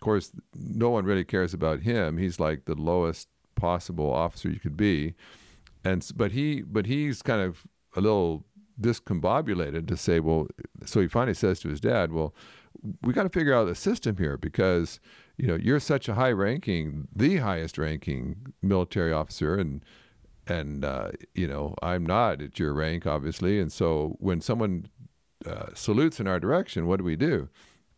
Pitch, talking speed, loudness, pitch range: 90 Hz, 175 wpm, -28 LUFS, 80-100 Hz